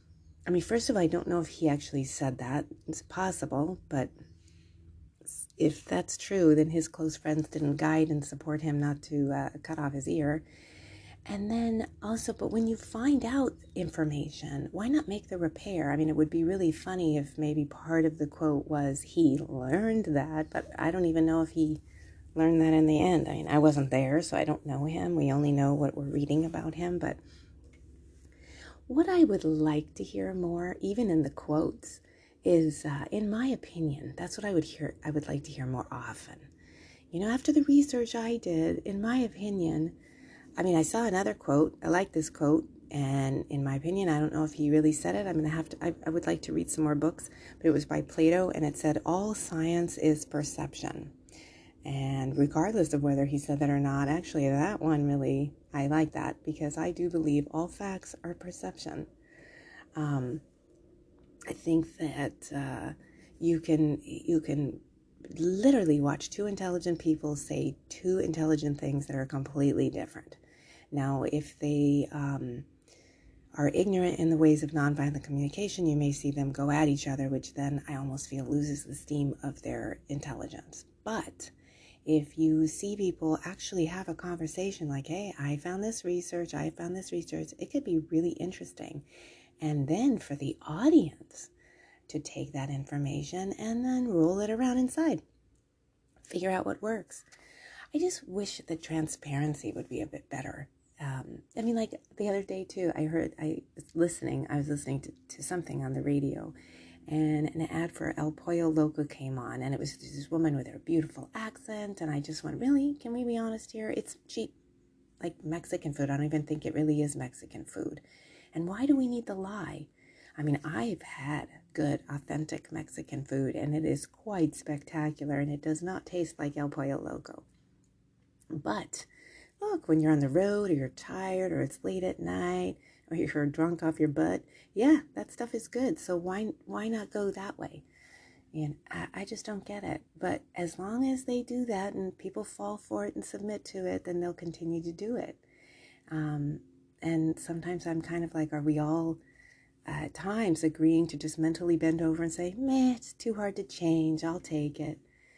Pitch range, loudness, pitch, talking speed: 145-175 Hz, -31 LUFS, 155 Hz, 190 wpm